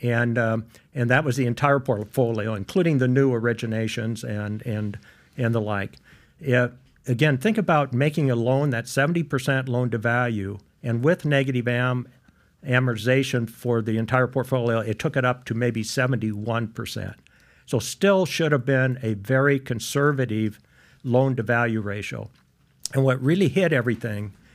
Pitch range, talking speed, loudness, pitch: 115-135 Hz, 150 wpm, -23 LUFS, 125 Hz